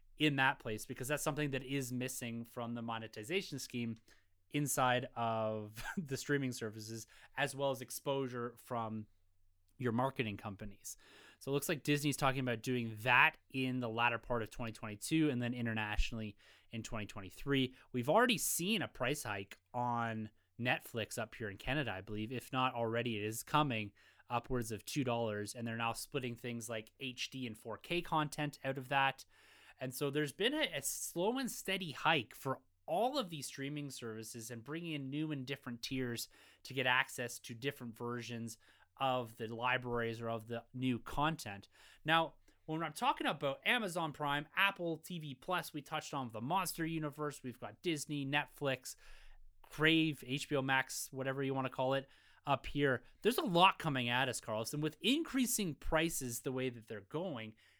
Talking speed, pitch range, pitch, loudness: 170 wpm, 115-150 Hz, 130 Hz, -38 LUFS